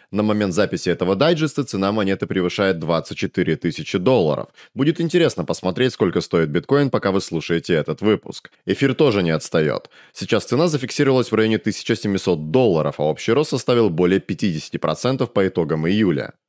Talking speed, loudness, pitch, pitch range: 155 wpm, -20 LUFS, 100 Hz, 90-125 Hz